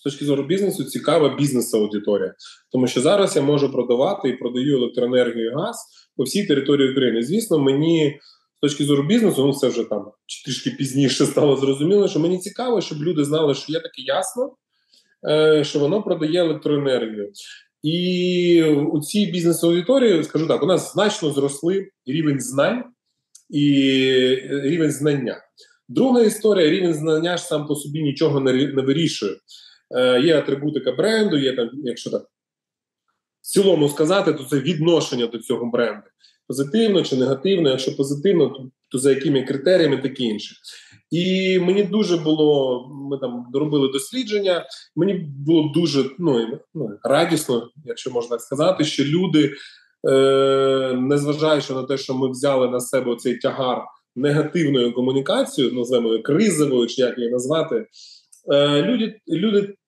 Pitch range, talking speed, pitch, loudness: 135-175 Hz, 145 wpm, 145 Hz, -20 LUFS